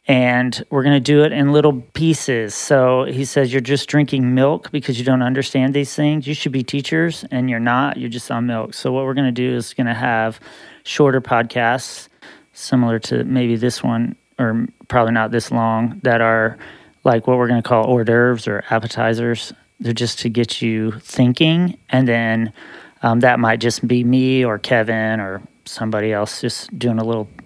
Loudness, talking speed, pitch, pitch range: -17 LUFS, 195 wpm, 125 Hz, 115-135 Hz